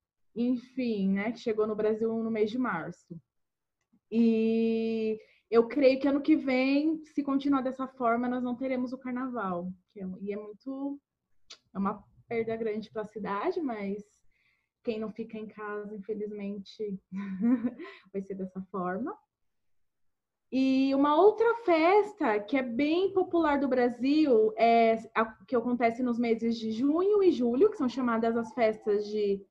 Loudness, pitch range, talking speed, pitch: -29 LUFS, 210-265 Hz, 155 wpm, 230 Hz